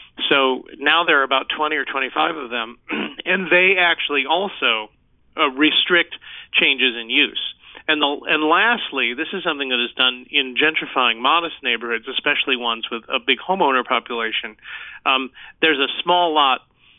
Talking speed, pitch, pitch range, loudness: 155 wpm, 140 Hz, 125-160 Hz, -18 LUFS